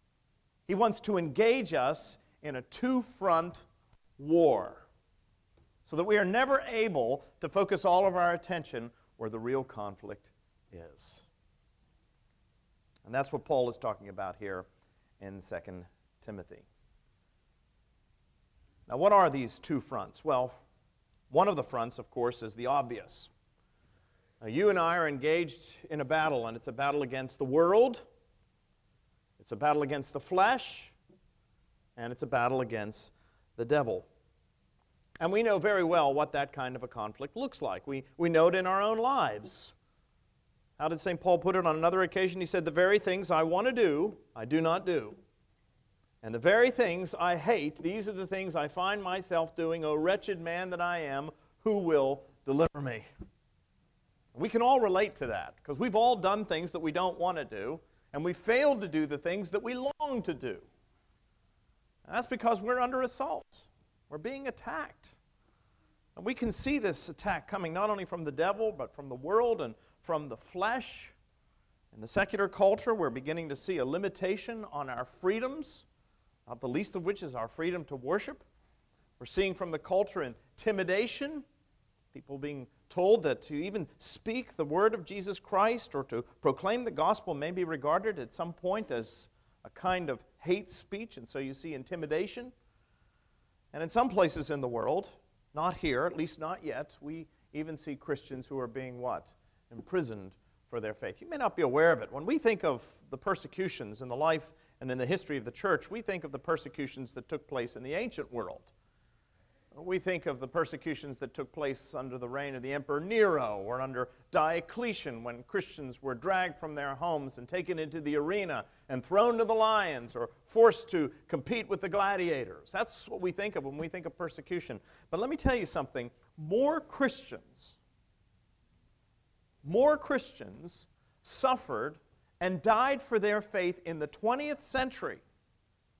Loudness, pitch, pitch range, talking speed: -32 LUFS, 165 Hz, 135-200 Hz, 180 wpm